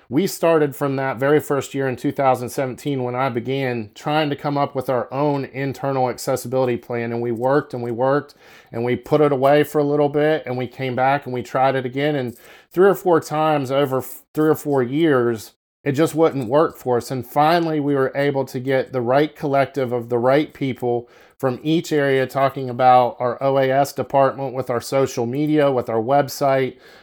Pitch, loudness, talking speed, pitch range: 135 Hz, -20 LUFS, 200 wpm, 125-145 Hz